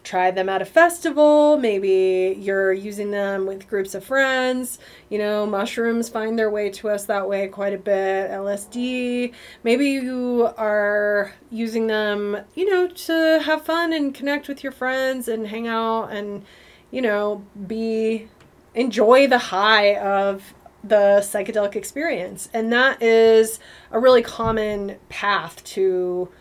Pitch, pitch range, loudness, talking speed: 220 Hz, 200-250 Hz, -20 LUFS, 145 wpm